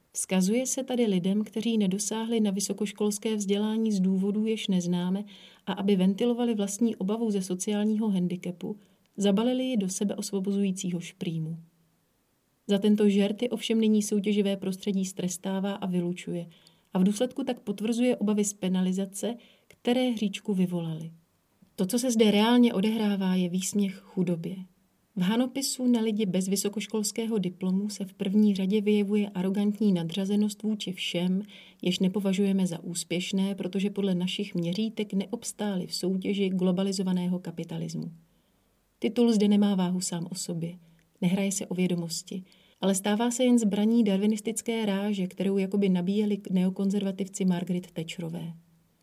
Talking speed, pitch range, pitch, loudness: 135 wpm, 185-215 Hz, 195 Hz, -28 LUFS